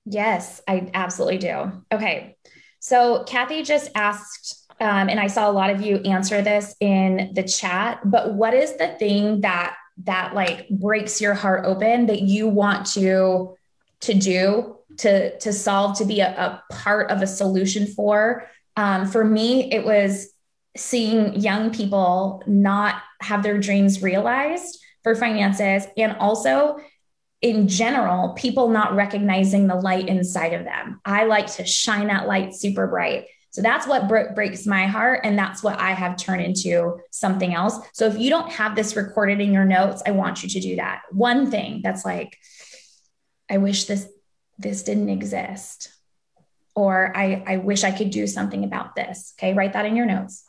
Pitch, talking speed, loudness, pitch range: 200 Hz, 170 wpm, -21 LUFS, 190-220 Hz